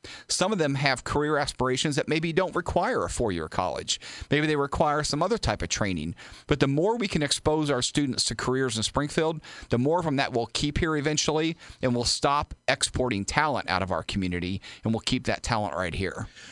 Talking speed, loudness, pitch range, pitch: 215 wpm, -26 LUFS, 120-155 Hz, 140 Hz